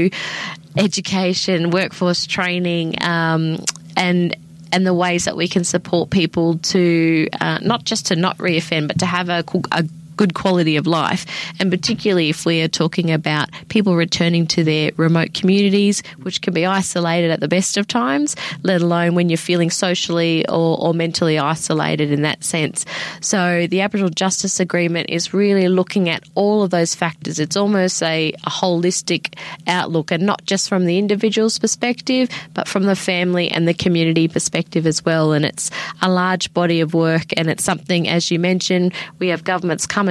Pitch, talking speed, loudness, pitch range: 175 Hz, 175 wpm, -18 LUFS, 165-190 Hz